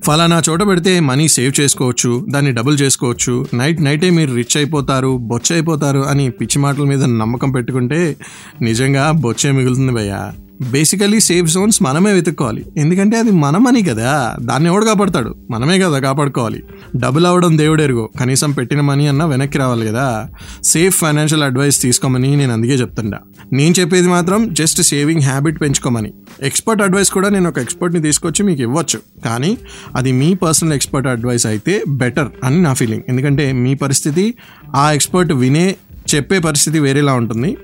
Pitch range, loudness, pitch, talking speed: 130-170 Hz, -14 LUFS, 145 Hz, 150 wpm